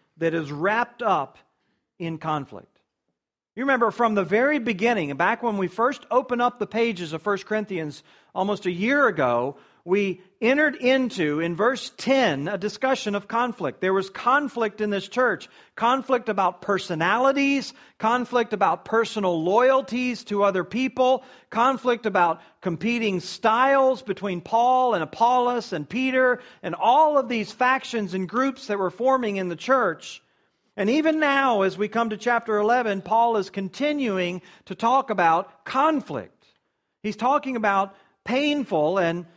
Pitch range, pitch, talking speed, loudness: 190-250 Hz, 220 Hz, 150 wpm, -23 LUFS